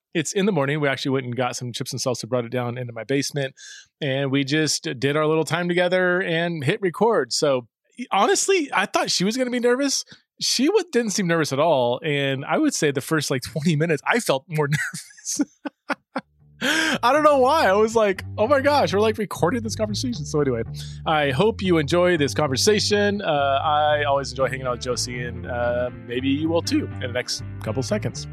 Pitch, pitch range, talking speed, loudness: 150 Hz, 125-200 Hz, 215 wpm, -22 LUFS